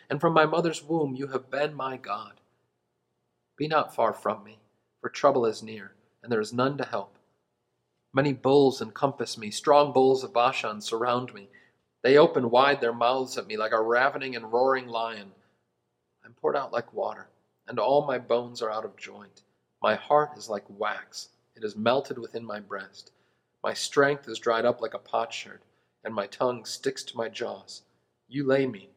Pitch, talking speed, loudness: 115 Hz, 190 wpm, -27 LUFS